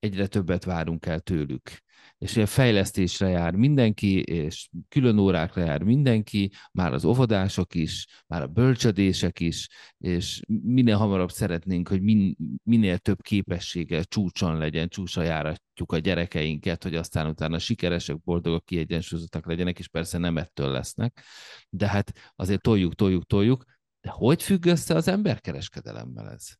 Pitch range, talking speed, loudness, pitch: 85-110 Hz, 140 wpm, -25 LUFS, 95 Hz